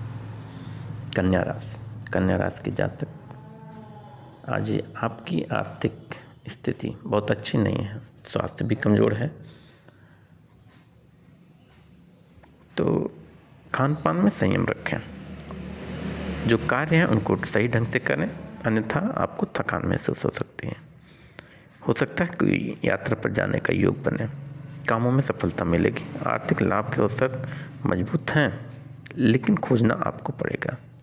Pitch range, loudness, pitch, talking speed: 110-140 Hz, -25 LUFS, 125 Hz, 120 wpm